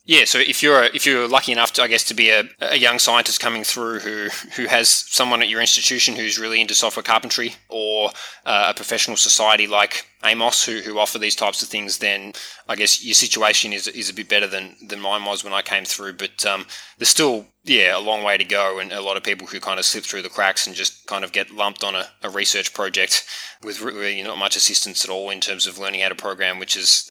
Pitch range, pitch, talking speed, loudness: 100-115 Hz, 105 Hz, 250 wpm, -18 LUFS